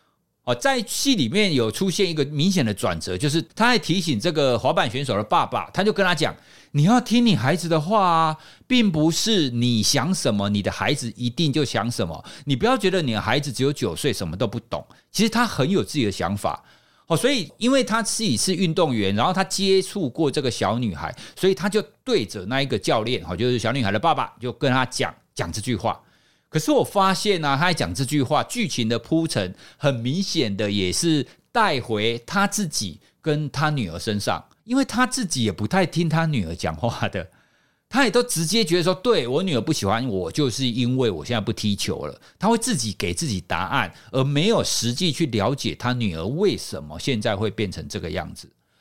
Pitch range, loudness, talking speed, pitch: 115-190 Hz, -22 LUFS, 305 characters per minute, 150 Hz